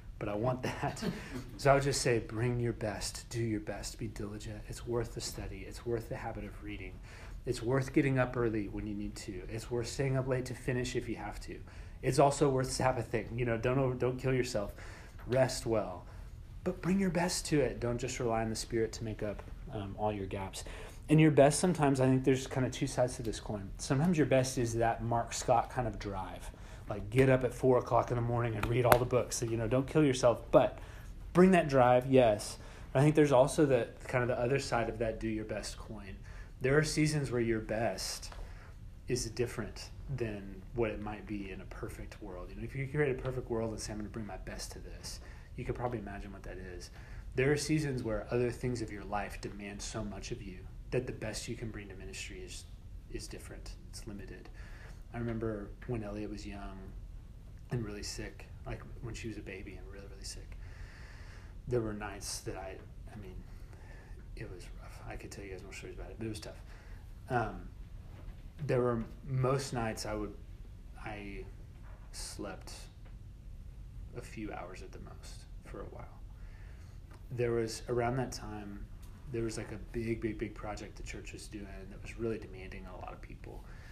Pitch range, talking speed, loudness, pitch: 100-120 Hz, 215 wpm, -34 LUFS, 110 Hz